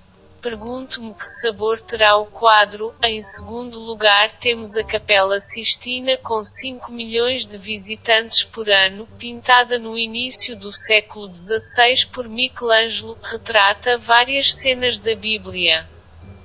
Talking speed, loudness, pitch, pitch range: 120 wpm, -15 LUFS, 225 Hz, 210-240 Hz